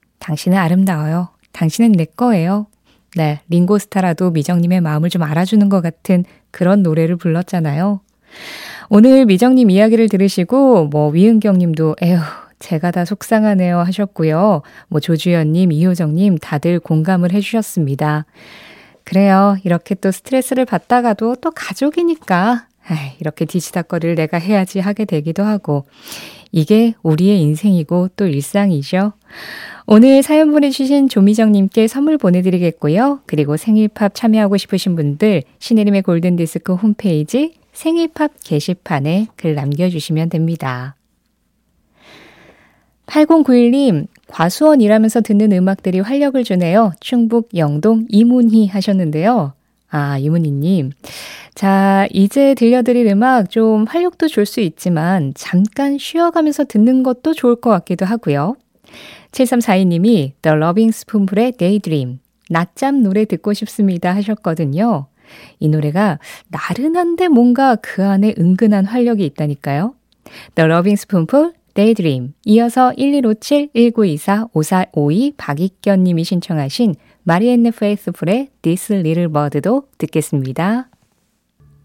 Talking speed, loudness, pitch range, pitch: 315 characters per minute, -14 LUFS, 165-225 Hz, 195 Hz